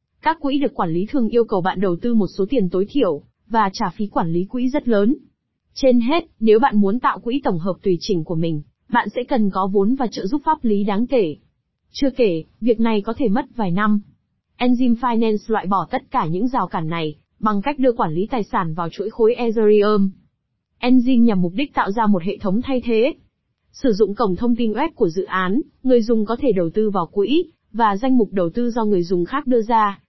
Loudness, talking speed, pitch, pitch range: -19 LUFS, 235 wpm, 220 Hz, 195-250 Hz